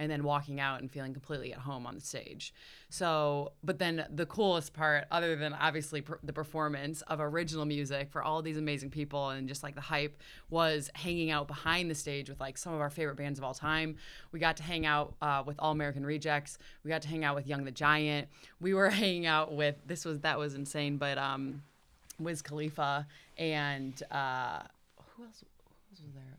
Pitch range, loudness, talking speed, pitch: 145-160 Hz, -34 LUFS, 215 wpm, 150 Hz